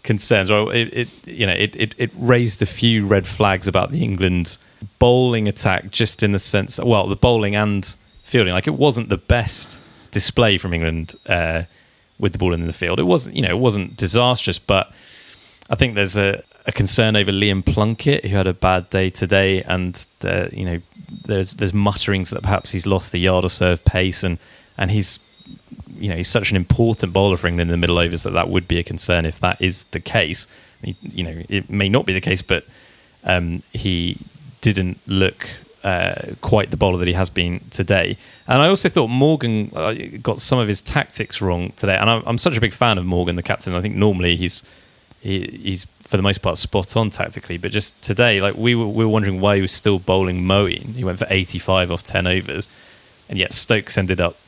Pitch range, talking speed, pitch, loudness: 90-115 Hz, 215 wpm, 100 Hz, -18 LUFS